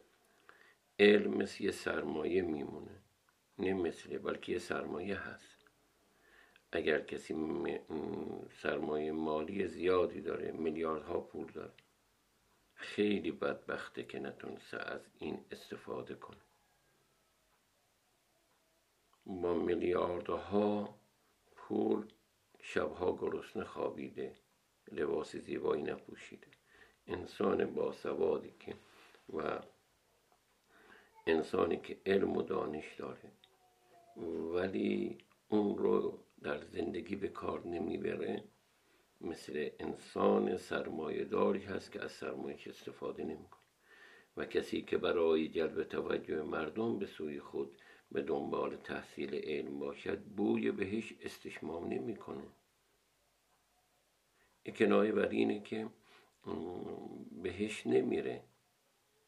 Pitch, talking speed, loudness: 395 Hz, 95 wpm, -38 LUFS